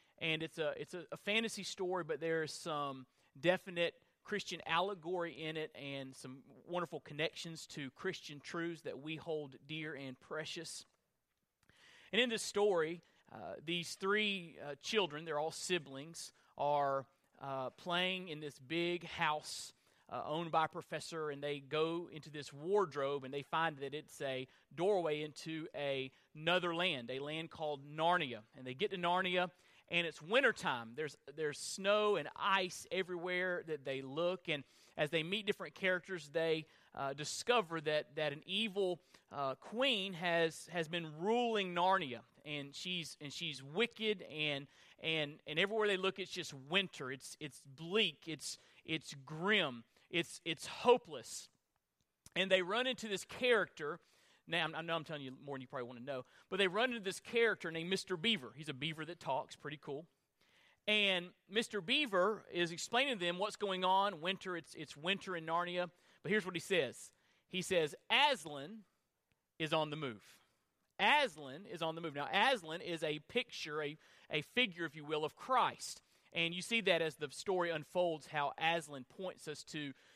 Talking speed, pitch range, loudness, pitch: 170 wpm, 150-185 Hz, -38 LUFS, 165 Hz